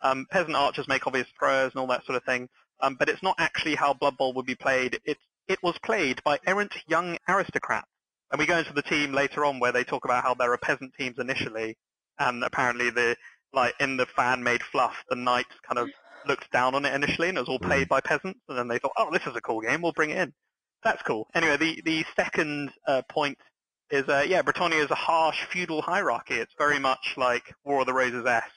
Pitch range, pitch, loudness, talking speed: 125-160 Hz, 140 Hz, -26 LUFS, 235 wpm